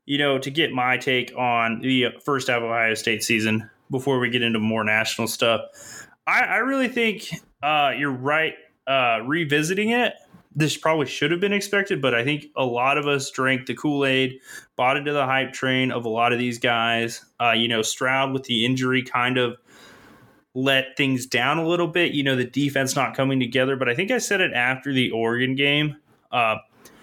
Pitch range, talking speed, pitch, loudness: 120-150 Hz, 205 wpm, 130 Hz, -22 LUFS